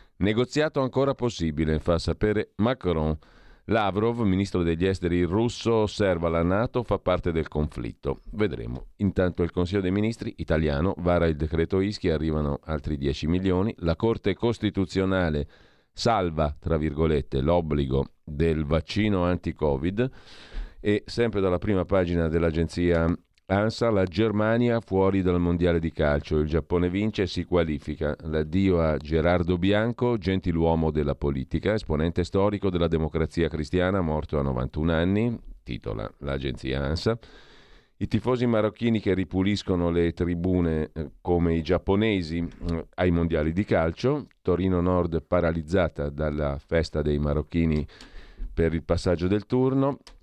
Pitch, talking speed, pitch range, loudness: 90 Hz, 130 wpm, 80-100 Hz, -26 LUFS